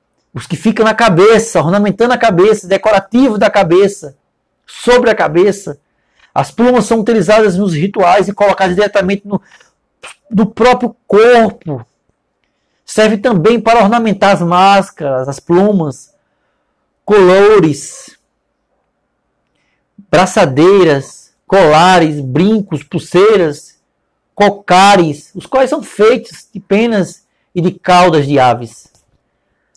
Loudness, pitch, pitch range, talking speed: -10 LUFS, 200 Hz, 175-225 Hz, 105 wpm